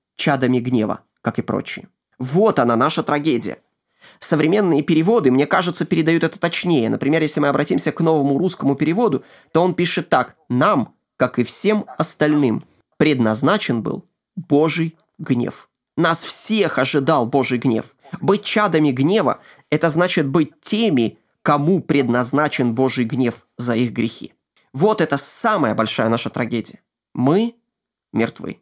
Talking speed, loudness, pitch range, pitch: 135 wpm, -19 LUFS, 125-170 Hz, 150 Hz